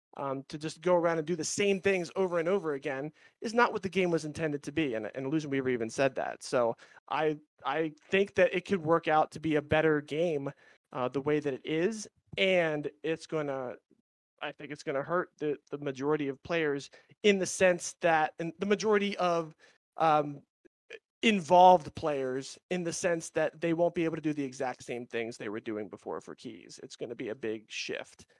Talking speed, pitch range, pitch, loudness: 210 wpm, 140-180 Hz, 160 Hz, -31 LUFS